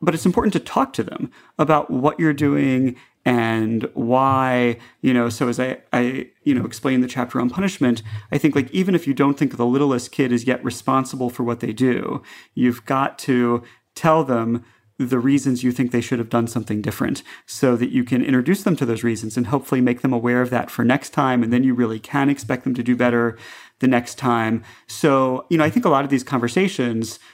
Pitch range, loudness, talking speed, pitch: 120-140 Hz, -20 LUFS, 220 wpm, 125 Hz